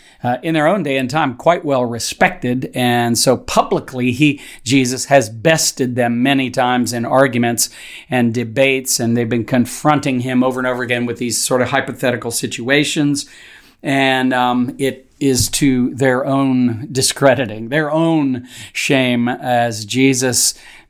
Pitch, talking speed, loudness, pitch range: 130 Hz, 150 wpm, -16 LUFS, 120-135 Hz